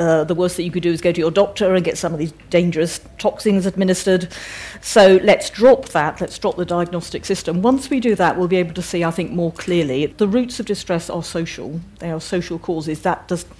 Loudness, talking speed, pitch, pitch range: -18 LUFS, 240 wpm, 175 Hz, 170-190 Hz